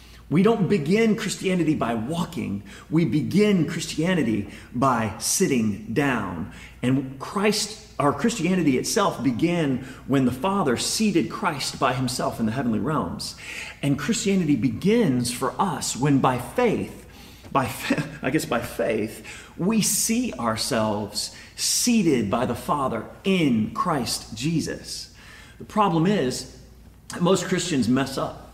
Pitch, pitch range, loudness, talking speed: 145 Hz, 120-195 Hz, -23 LUFS, 125 wpm